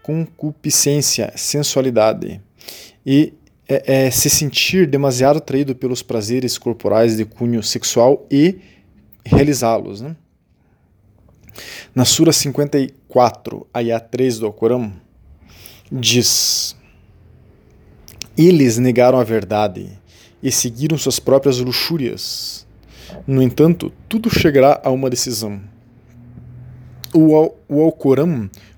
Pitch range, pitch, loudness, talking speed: 115-145 Hz, 125 Hz, -15 LUFS, 90 wpm